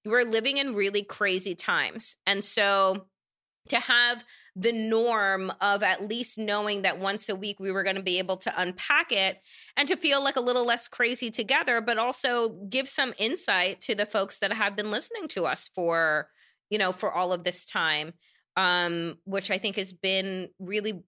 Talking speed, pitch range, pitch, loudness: 190 wpm, 190-235 Hz, 205 Hz, -26 LUFS